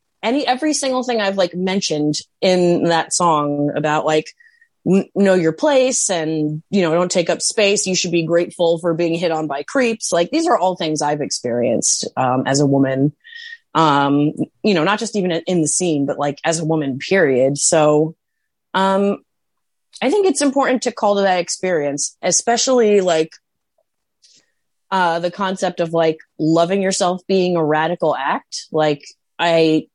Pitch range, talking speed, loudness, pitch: 155-200 Hz, 170 wpm, -17 LUFS, 175 Hz